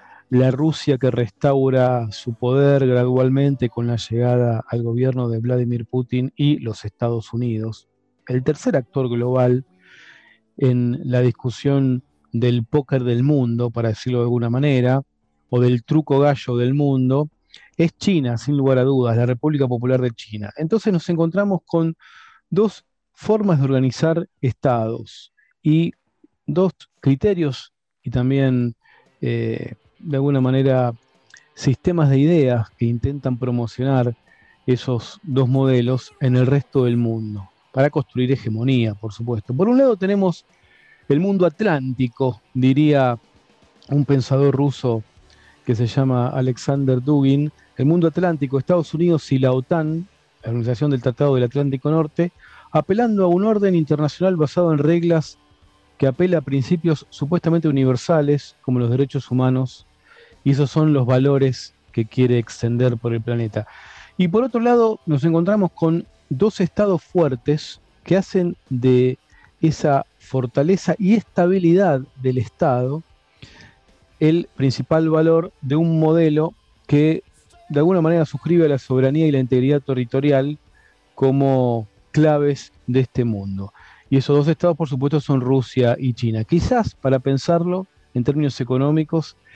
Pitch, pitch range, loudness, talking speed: 135 Hz, 125-160 Hz, -19 LUFS, 140 wpm